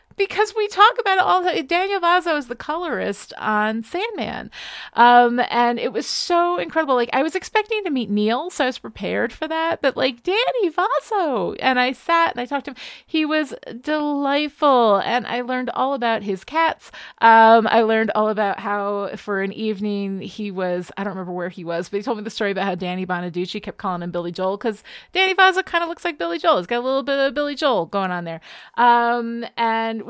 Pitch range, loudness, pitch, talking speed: 205-320 Hz, -20 LUFS, 240 Hz, 220 wpm